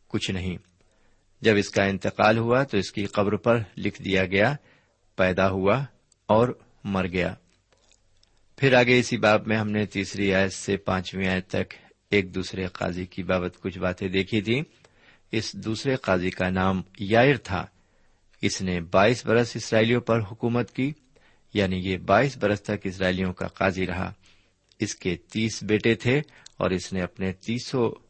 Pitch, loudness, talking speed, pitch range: 100 Hz, -25 LUFS, 165 wpm, 95-115 Hz